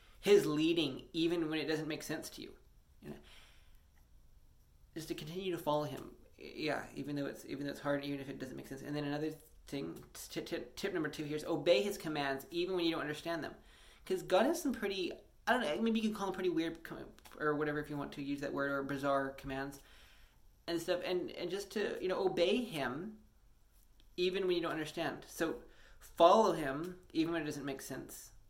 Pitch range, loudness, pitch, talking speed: 135-175 Hz, -37 LUFS, 150 Hz, 215 wpm